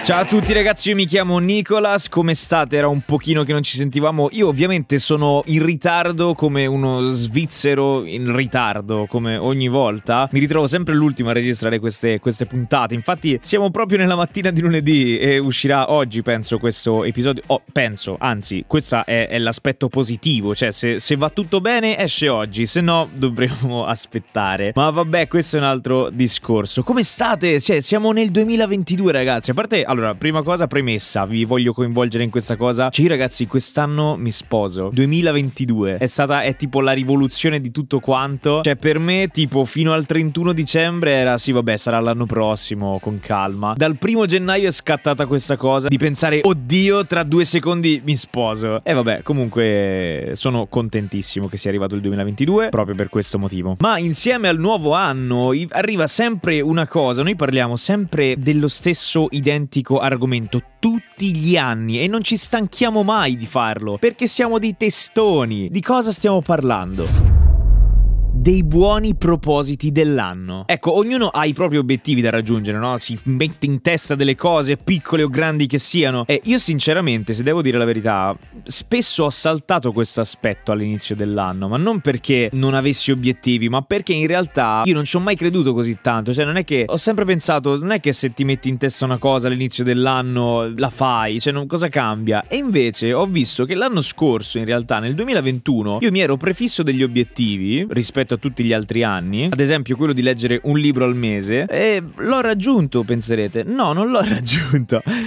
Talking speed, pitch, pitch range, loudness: 180 wpm, 140 Hz, 120-170 Hz, -18 LUFS